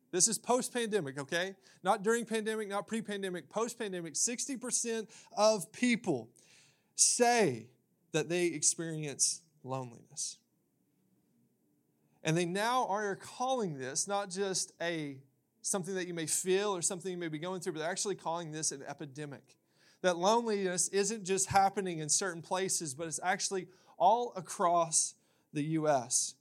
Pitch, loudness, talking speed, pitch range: 185 Hz, -33 LUFS, 140 wpm, 160-205 Hz